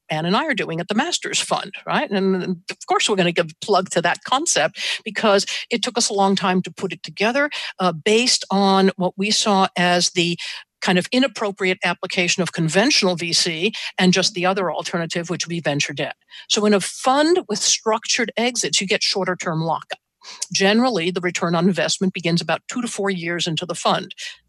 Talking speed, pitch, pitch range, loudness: 205 wpm, 190 Hz, 175-215 Hz, -19 LUFS